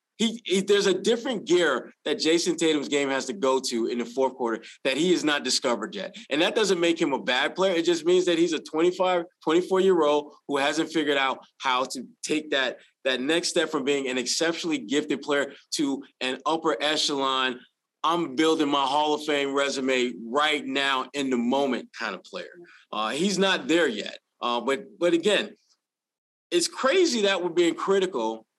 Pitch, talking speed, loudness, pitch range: 155 Hz, 190 wpm, -25 LUFS, 135-180 Hz